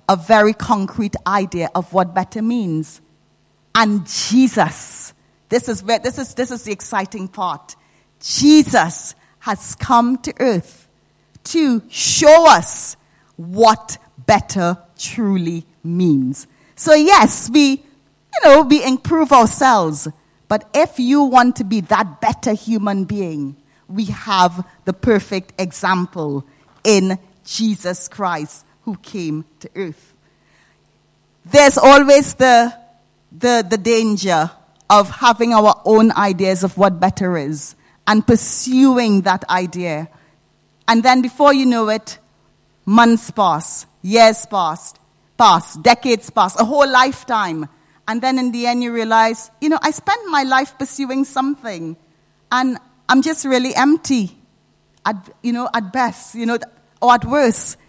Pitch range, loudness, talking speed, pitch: 180-250 Hz, -14 LUFS, 130 wpm, 220 Hz